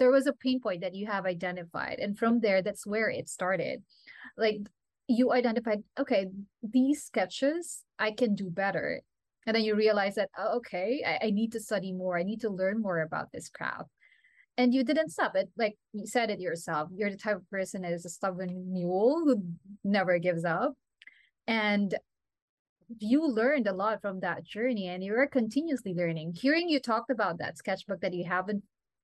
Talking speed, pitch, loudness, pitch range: 190 wpm, 210 Hz, -30 LUFS, 185-245 Hz